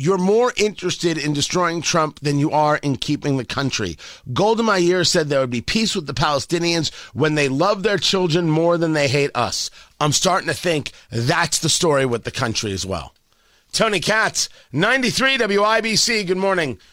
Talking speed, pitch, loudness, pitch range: 180 wpm, 160 Hz, -19 LUFS, 140-185 Hz